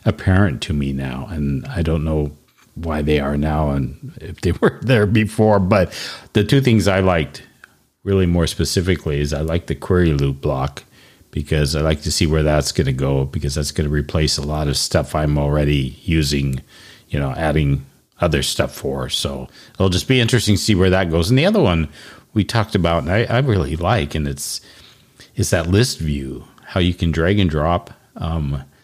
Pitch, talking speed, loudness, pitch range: 80 Hz, 200 wpm, -18 LUFS, 75-100 Hz